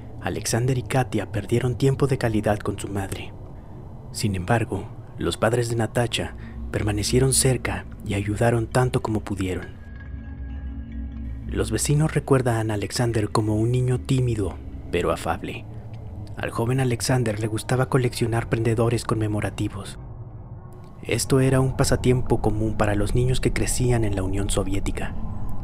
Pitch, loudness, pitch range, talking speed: 110 Hz, -24 LUFS, 100-120 Hz, 130 wpm